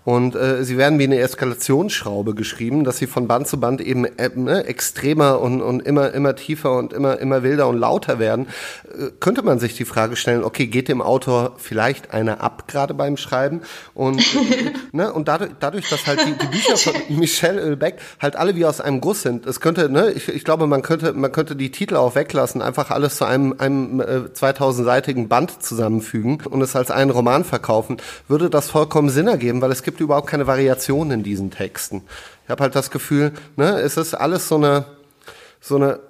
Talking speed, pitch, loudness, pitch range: 205 wpm, 135 Hz, -19 LUFS, 125-150 Hz